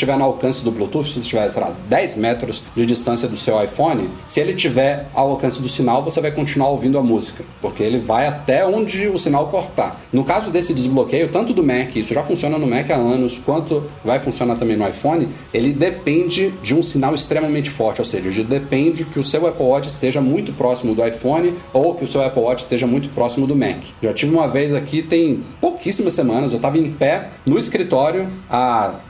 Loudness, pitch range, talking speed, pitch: -18 LUFS, 125-160 Hz, 215 wpm, 140 Hz